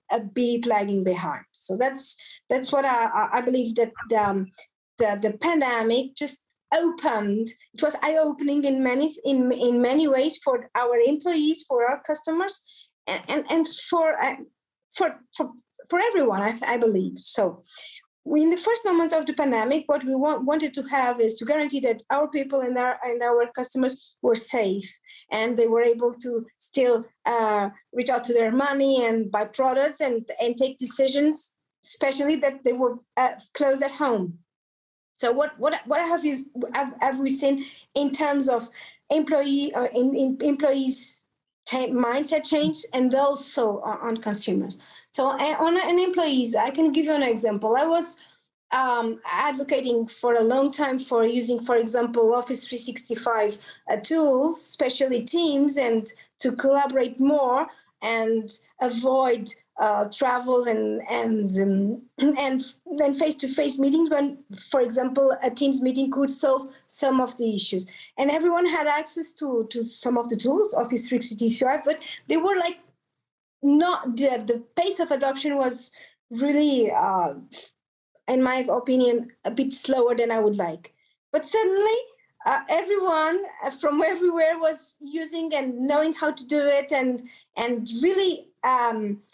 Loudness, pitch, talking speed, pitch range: -24 LUFS, 265 Hz, 155 wpm, 235-295 Hz